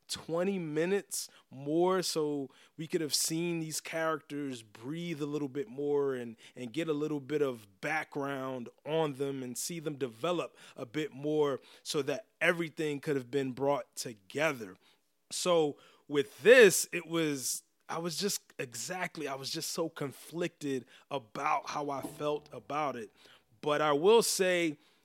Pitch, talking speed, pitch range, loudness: 150 Hz, 155 wpm, 140-165 Hz, -32 LUFS